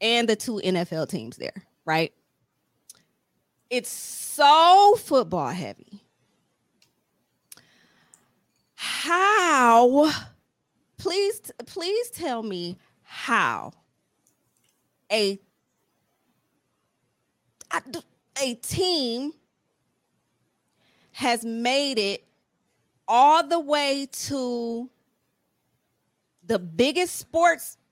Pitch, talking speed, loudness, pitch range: 245 Hz, 65 wpm, -23 LUFS, 215-330 Hz